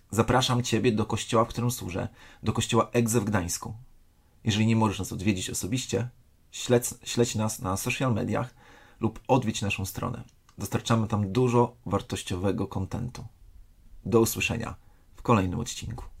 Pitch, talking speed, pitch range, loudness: 115 Hz, 140 wpm, 95-120 Hz, -27 LUFS